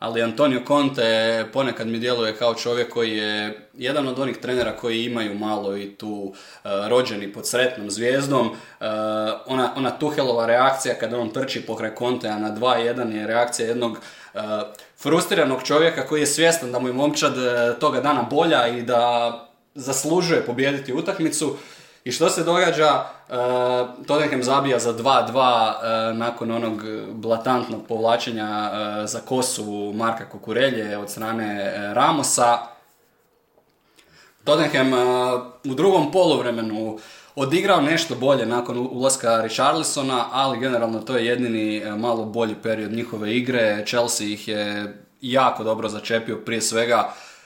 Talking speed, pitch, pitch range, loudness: 140 wpm, 120 Hz, 110-130 Hz, -22 LUFS